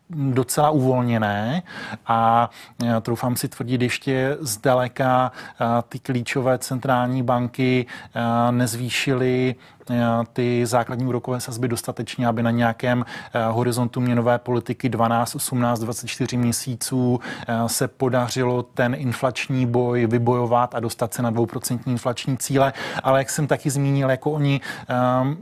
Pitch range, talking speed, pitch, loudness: 120-130 Hz, 115 wpm, 125 Hz, -22 LUFS